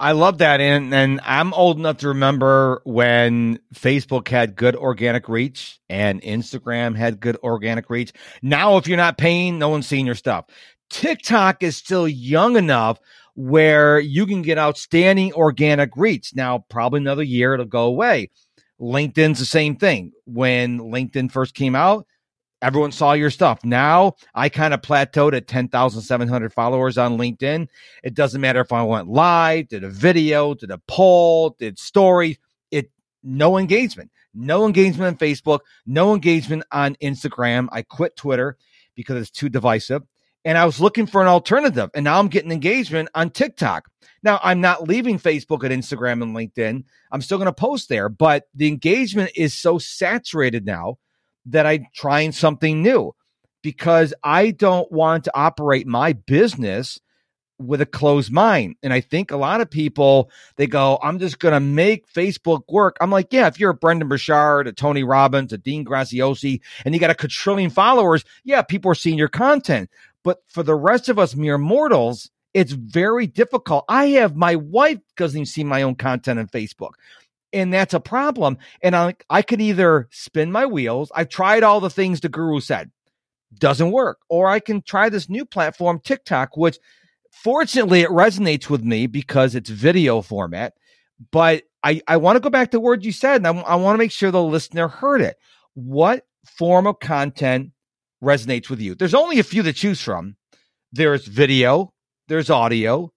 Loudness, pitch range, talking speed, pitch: -18 LUFS, 130-180 Hz, 180 wpm, 150 Hz